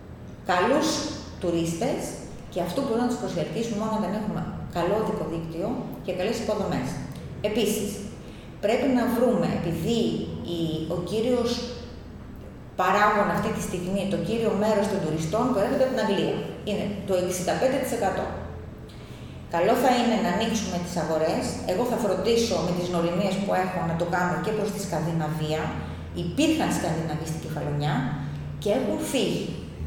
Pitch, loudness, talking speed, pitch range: 200 Hz, -26 LUFS, 145 wpm, 170-225 Hz